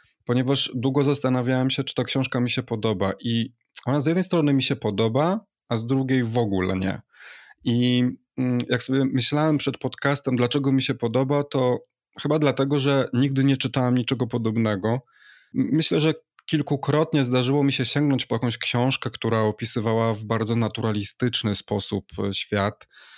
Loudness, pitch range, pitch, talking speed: -23 LUFS, 115-140 Hz, 130 Hz, 155 wpm